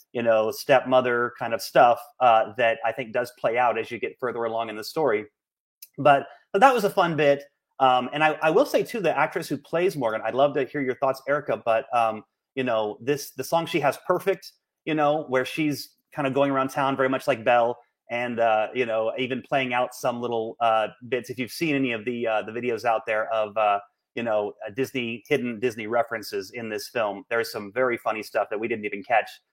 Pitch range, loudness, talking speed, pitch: 115-140 Hz, -24 LUFS, 230 wpm, 125 Hz